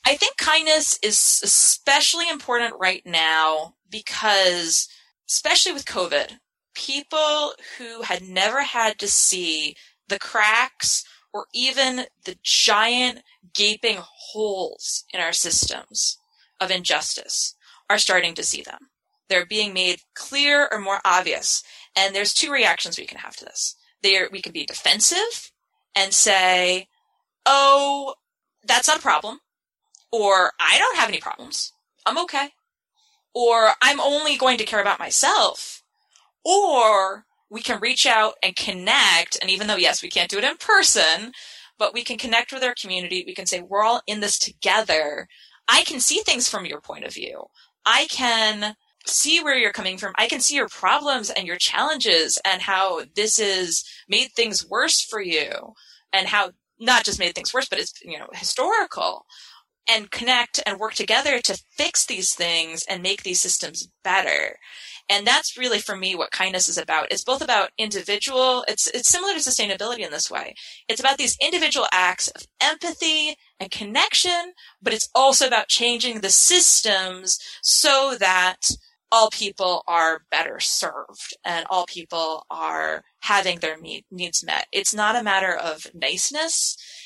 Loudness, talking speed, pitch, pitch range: -20 LUFS, 160 wpm, 220 Hz, 190-280 Hz